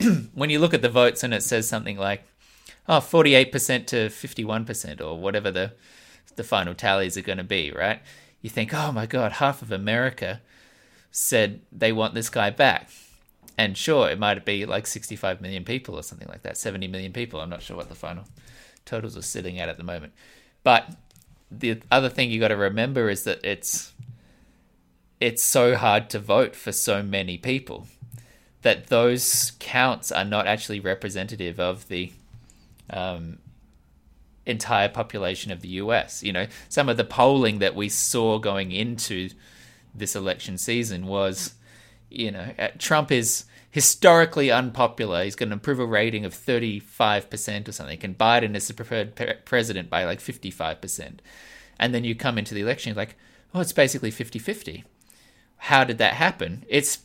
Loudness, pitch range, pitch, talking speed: -23 LUFS, 95-120 Hz, 110 Hz, 175 wpm